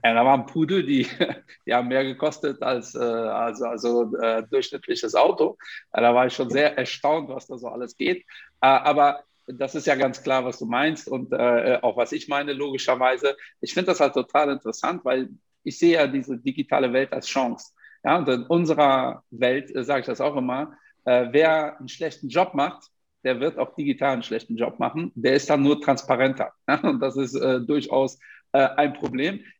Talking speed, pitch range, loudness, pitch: 195 wpm, 125-155 Hz, -23 LUFS, 135 Hz